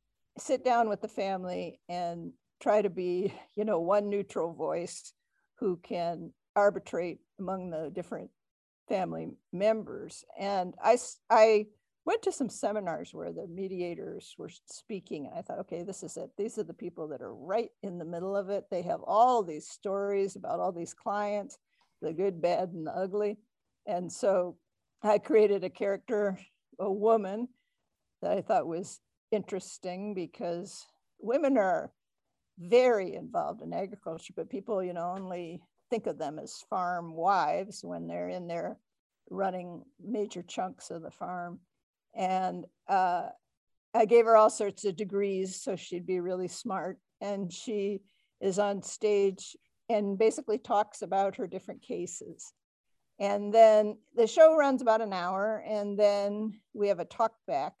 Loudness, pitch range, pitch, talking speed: -31 LUFS, 180-215 Hz, 200 Hz, 155 wpm